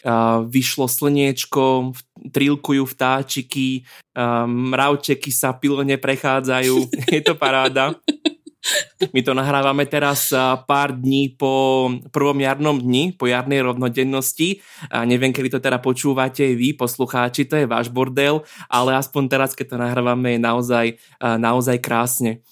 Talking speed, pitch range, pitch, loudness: 135 wpm, 125-140 Hz, 130 Hz, -19 LUFS